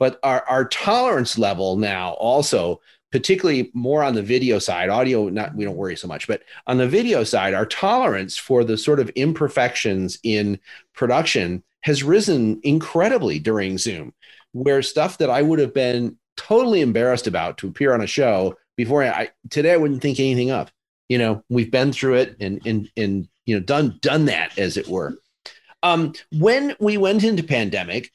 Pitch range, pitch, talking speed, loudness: 110-150 Hz, 130 Hz, 185 wpm, -20 LUFS